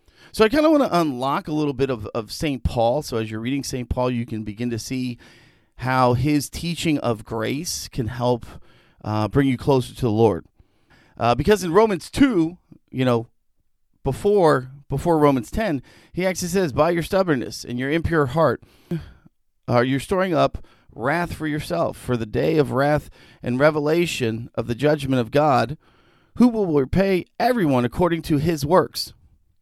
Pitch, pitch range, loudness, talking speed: 135 Hz, 120-165 Hz, -21 LUFS, 175 wpm